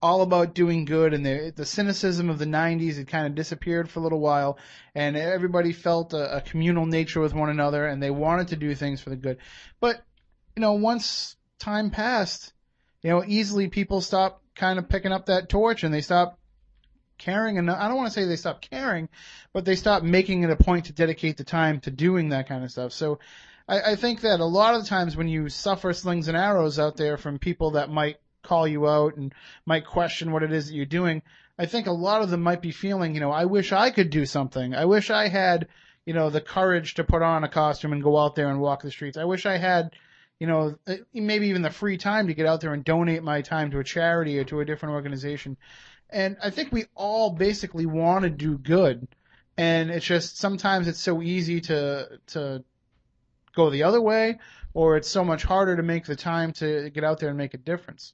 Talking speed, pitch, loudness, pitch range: 230 wpm, 165 Hz, -25 LUFS, 150-185 Hz